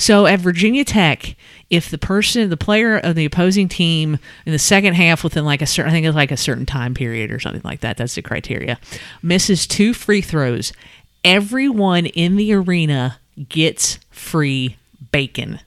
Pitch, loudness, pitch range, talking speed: 165 Hz, -16 LUFS, 140-195 Hz, 180 wpm